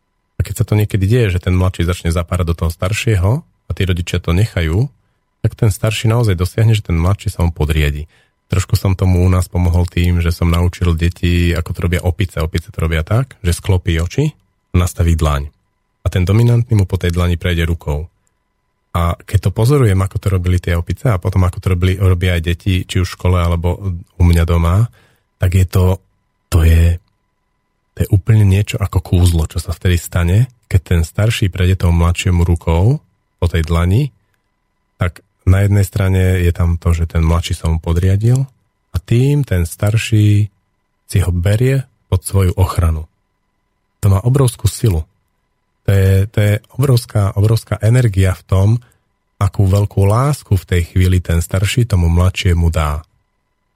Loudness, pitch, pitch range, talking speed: -15 LUFS, 95 Hz, 85-105 Hz, 180 wpm